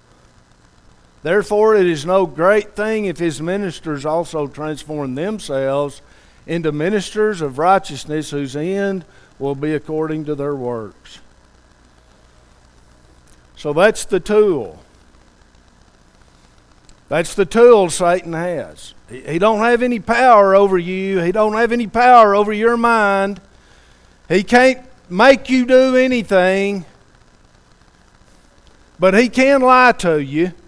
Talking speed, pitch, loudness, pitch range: 115 wpm, 175 Hz, -15 LUFS, 135-210 Hz